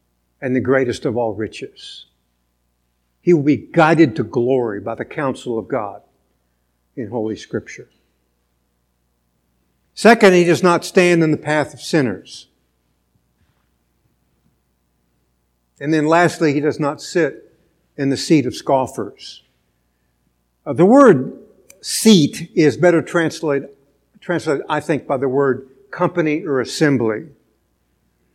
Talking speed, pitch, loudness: 125 wpm, 125 Hz, -17 LUFS